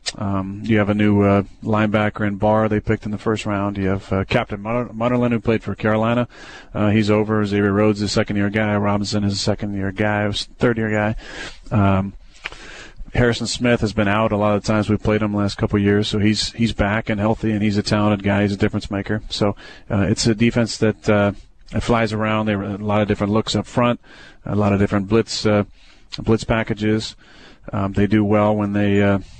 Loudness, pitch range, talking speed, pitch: -19 LUFS, 100-110 Hz, 220 wpm, 105 Hz